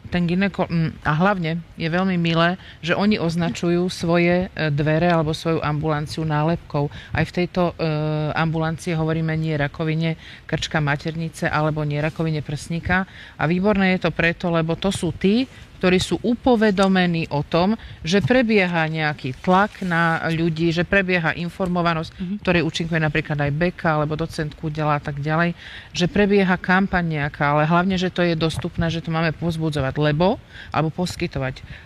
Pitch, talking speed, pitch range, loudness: 165 Hz, 150 wpm, 155-180 Hz, -21 LUFS